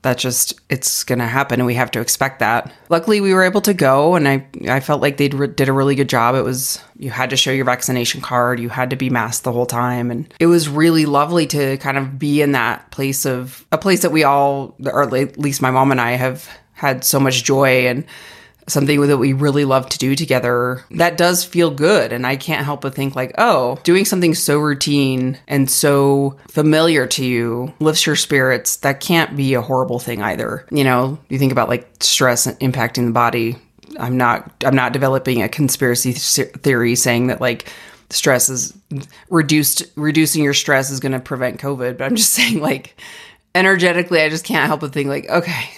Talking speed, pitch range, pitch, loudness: 210 wpm, 125-150 Hz, 135 Hz, -16 LUFS